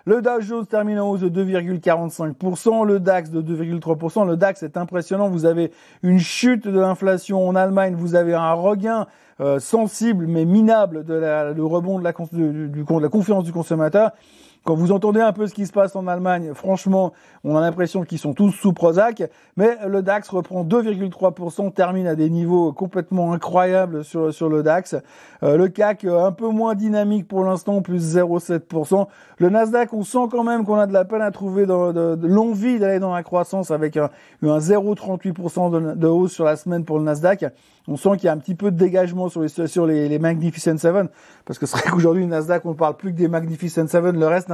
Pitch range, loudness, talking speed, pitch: 165-200 Hz, -19 LUFS, 215 wpm, 180 Hz